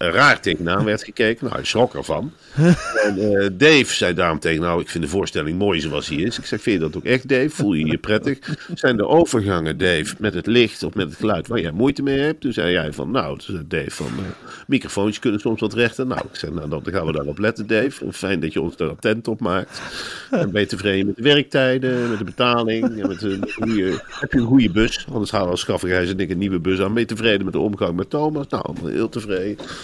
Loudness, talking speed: -20 LUFS, 245 wpm